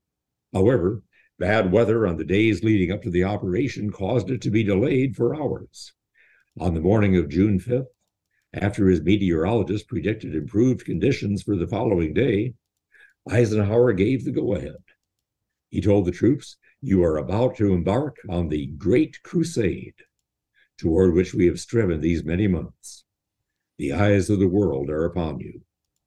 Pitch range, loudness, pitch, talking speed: 90-110 Hz, -22 LUFS, 100 Hz, 155 wpm